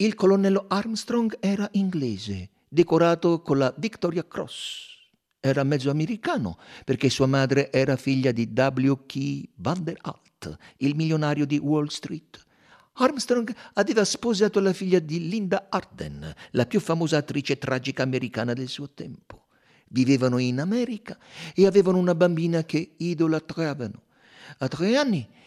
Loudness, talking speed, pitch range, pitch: -24 LUFS, 130 wpm, 135-195 Hz, 155 Hz